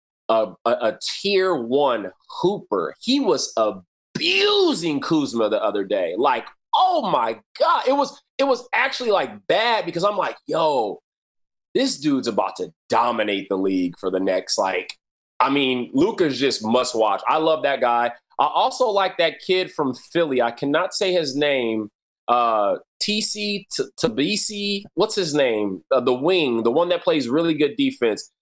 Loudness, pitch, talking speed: -21 LUFS, 175 Hz, 165 wpm